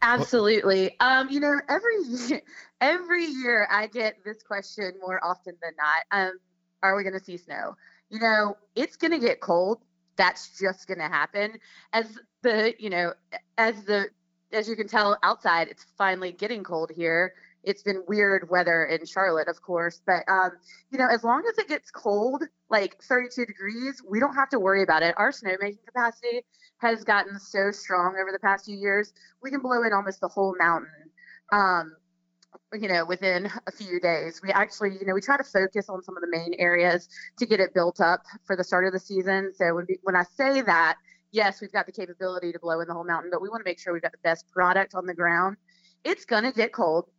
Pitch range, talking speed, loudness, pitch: 180-225 Hz, 210 wpm, -25 LUFS, 195 Hz